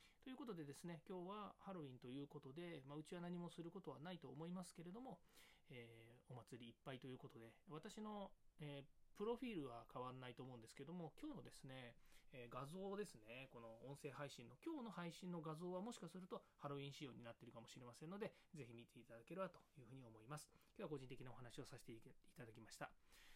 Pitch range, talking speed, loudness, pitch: 125-180 Hz, 470 characters per minute, -57 LUFS, 145 Hz